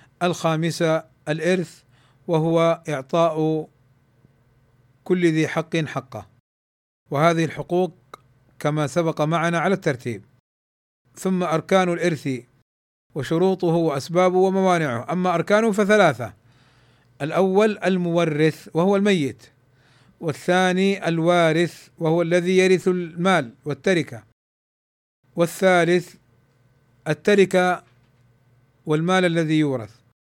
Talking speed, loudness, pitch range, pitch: 80 wpm, -21 LUFS, 125-180 Hz, 160 Hz